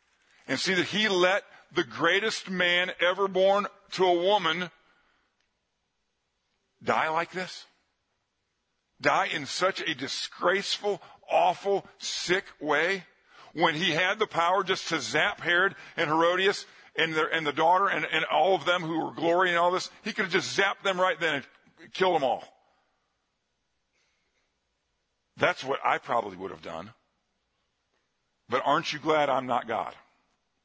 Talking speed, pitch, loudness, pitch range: 150 wpm, 180 Hz, -26 LUFS, 165-195 Hz